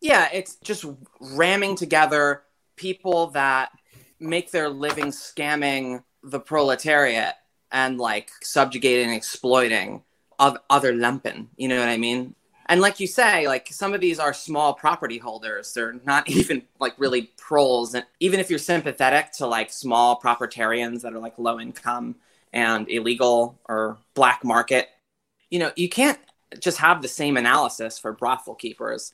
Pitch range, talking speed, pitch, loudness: 120-155 Hz, 150 wpm, 135 Hz, -22 LUFS